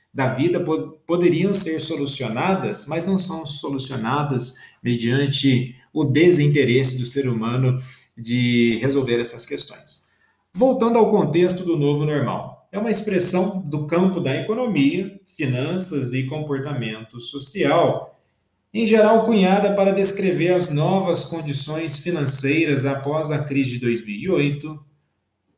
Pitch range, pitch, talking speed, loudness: 130-180 Hz, 150 Hz, 115 wpm, -17 LUFS